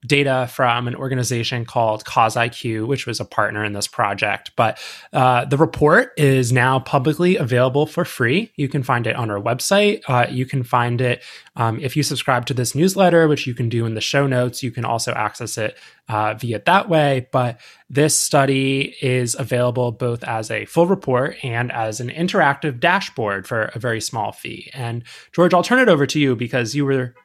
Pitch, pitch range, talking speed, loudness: 125 Hz, 120-145 Hz, 200 wpm, -19 LUFS